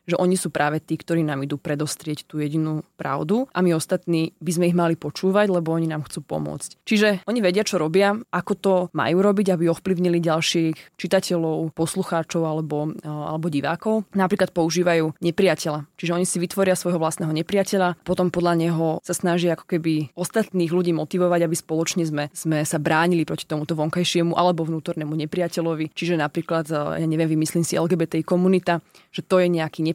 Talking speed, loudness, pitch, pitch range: 175 wpm, -22 LUFS, 170 Hz, 160-180 Hz